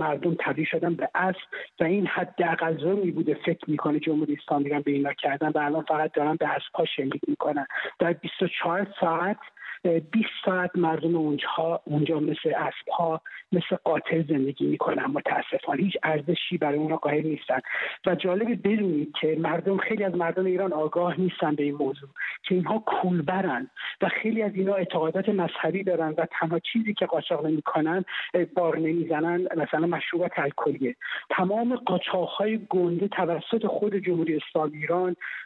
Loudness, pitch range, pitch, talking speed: -26 LUFS, 155-185 Hz, 170 Hz, 155 wpm